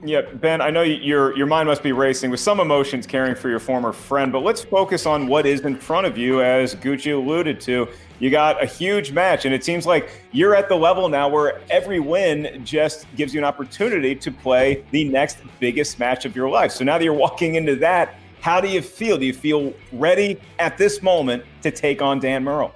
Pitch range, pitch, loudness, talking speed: 130-160 Hz, 145 Hz, -20 LUFS, 225 wpm